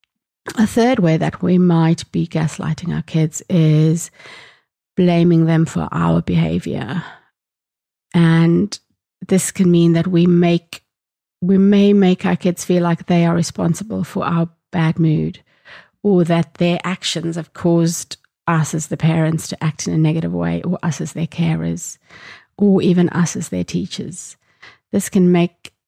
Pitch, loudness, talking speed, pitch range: 170 Hz, -17 LUFS, 155 wpm, 160-180 Hz